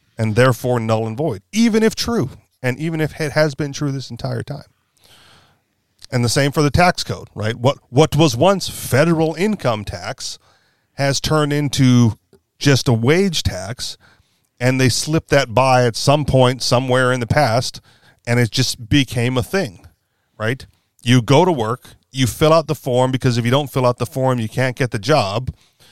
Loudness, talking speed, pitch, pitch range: -17 LUFS, 190 wpm, 130 Hz, 120-150 Hz